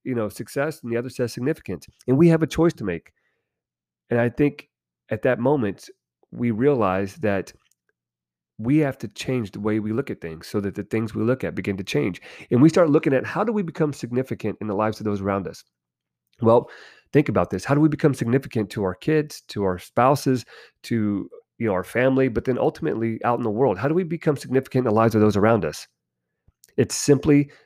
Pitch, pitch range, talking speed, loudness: 115 Hz, 100-140 Hz, 220 wpm, -22 LUFS